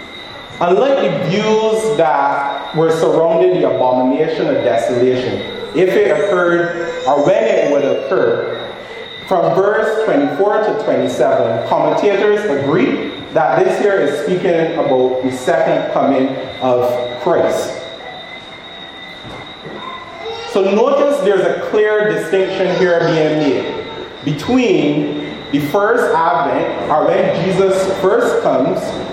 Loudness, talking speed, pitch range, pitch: -14 LUFS, 110 wpm, 145-215 Hz, 185 Hz